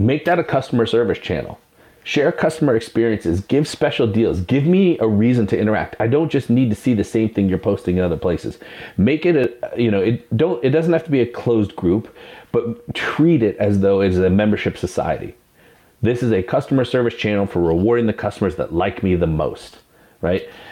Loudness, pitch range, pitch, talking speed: -18 LUFS, 100-125 Hz, 115 Hz, 210 wpm